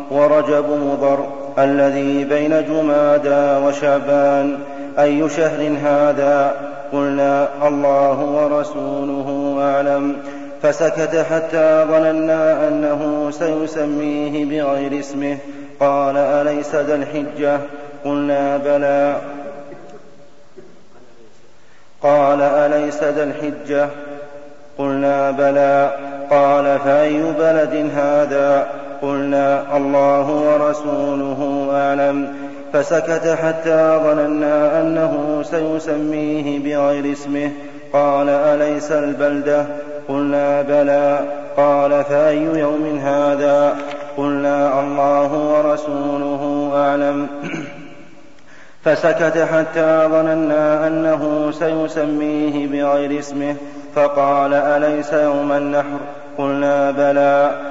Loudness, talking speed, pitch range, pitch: -17 LUFS, 75 wpm, 140-150 Hz, 145 Hz